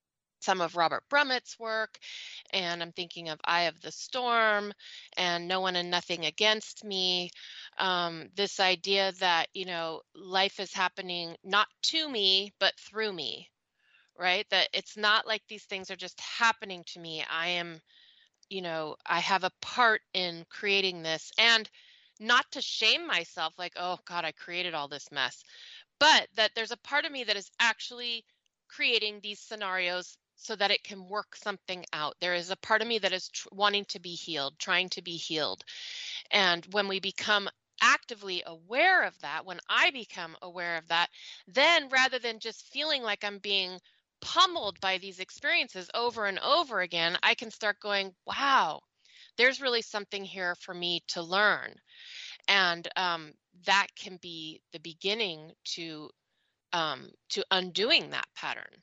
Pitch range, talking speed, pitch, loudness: 175-220 Hz, 165 wpm, 195 Hz, -29 LUFS